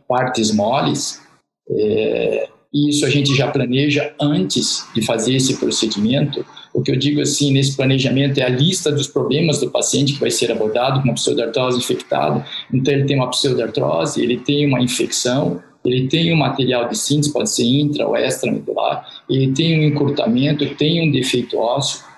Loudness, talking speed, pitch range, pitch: -17 LUFS, 175 wpm, 130-145 Hz, 140 Hz